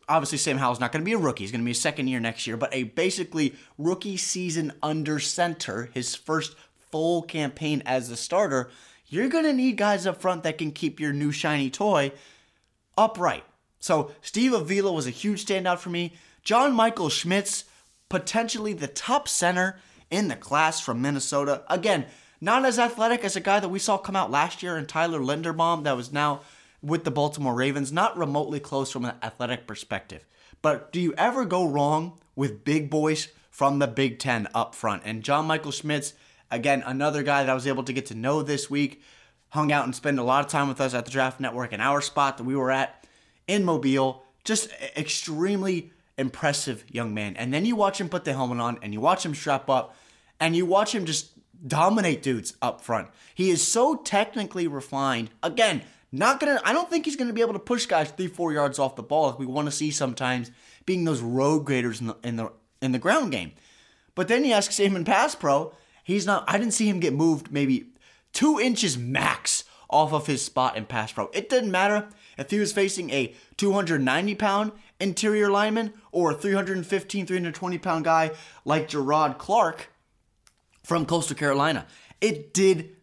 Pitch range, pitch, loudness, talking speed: 135-190 Hz, 155 Hz, -25 LUFS, 200 wpm